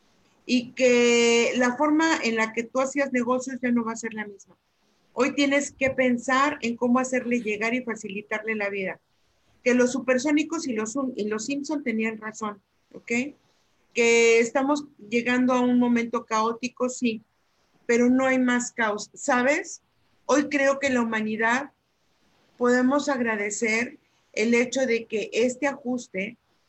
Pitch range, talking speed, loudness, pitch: 225-260 Hz, 150 wpm, -24 LUFS, 245 Hz